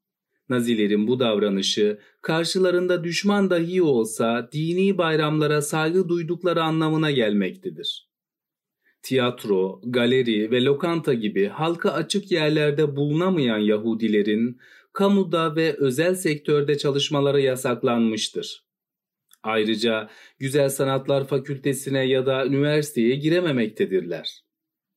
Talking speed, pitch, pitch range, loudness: 90 wpm, 145 Hz, 120-170 Hz, -22 LUFS